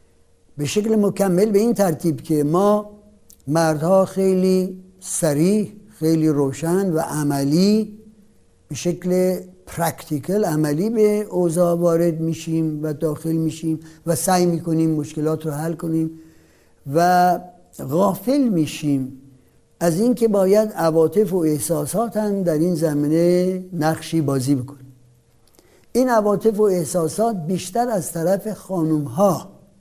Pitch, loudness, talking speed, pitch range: 170 Hz, -20 LUFS, 115 wpm, 155-195 Hz